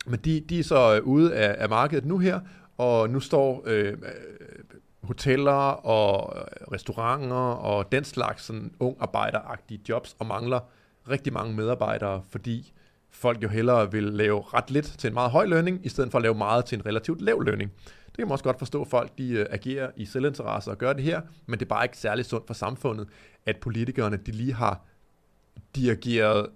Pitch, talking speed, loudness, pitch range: 120 Hz, 190 wpm, -26 LUFS, 110-135 Hz